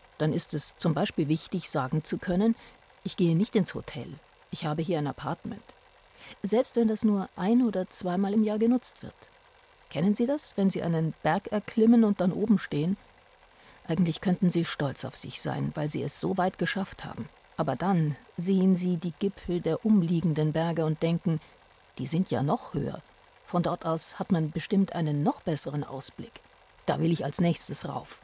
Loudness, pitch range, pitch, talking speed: -28 LUFS, 160-200 Hz, 180 Hz, 185 wpm